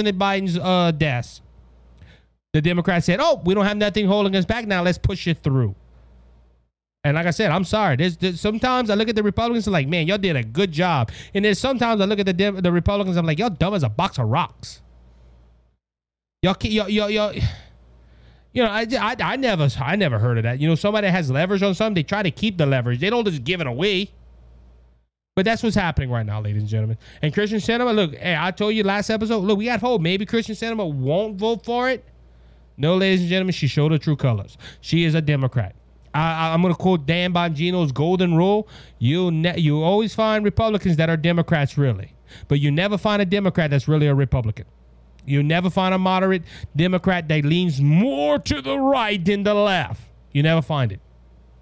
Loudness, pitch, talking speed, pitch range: -20 LUFS, 170 Hz, 220 wpm, 130-205 Hz